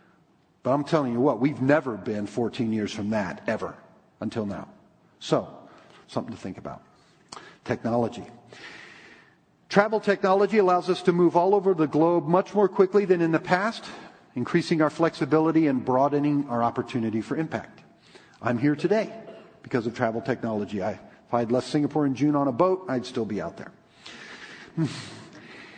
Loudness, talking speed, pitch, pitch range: -25 LUFS, 165 wpm, 150 Hz, 125-180 Hz